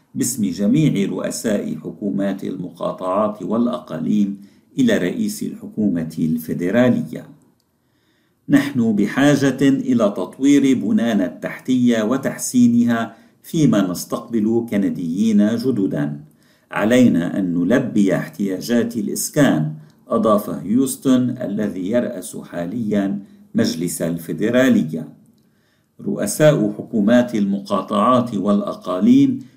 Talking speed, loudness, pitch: 75 wpm, -19 LUFS, 120 Hz